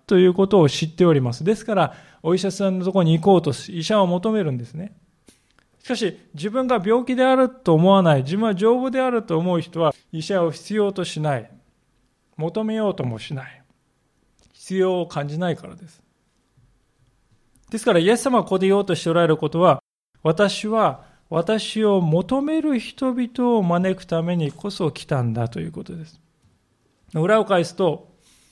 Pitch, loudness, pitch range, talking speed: 180 Hz, -20 LUFS, 155-210 Hz, 330 characters per minute